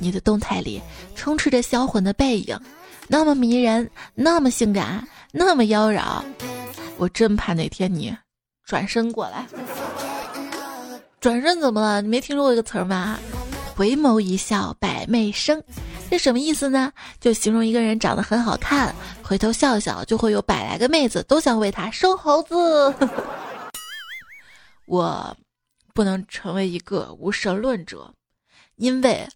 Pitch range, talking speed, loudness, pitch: 205-275 Hz, 215 characters per minute, -21 LUFS, 230 Hz